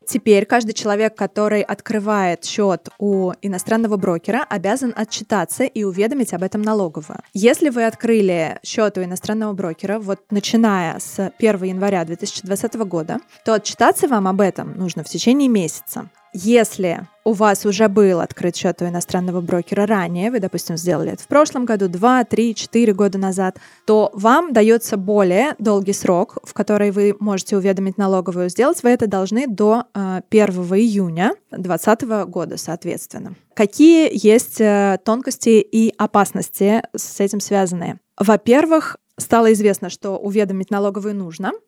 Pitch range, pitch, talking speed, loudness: 190-225 Hz, 205 Hz, 145 wpm, -17 LUFS